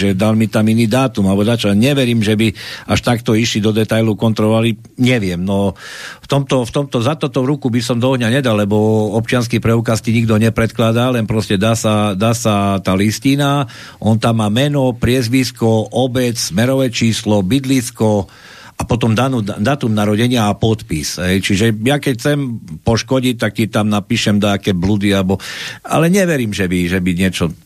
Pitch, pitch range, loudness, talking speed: 115 Hz, 105-125 Hz, -15 LUFS, 175 wpm